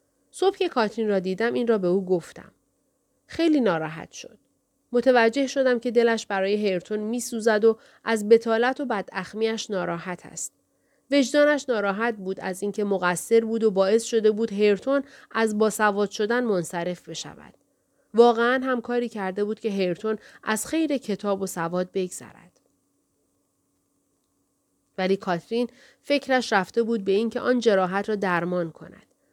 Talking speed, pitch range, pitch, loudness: 140 wpm, 195-245 Hz, 220 Hz, -24 LUFS